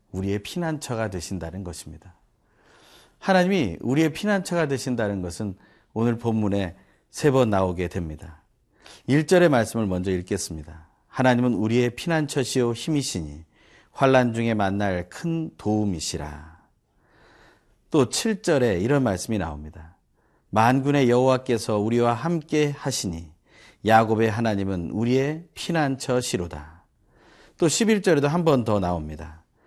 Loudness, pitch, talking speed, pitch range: -23 LUFS, 110 Hz, 285 characters per minute, 90-135 Hz